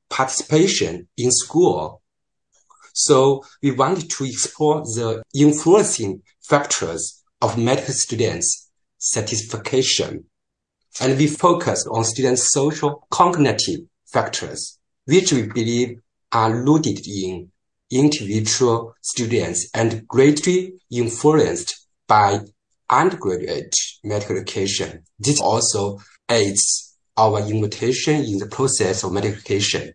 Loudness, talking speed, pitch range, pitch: -19 LUFS, 100 wpm, 105-140 Hz, 120 Hz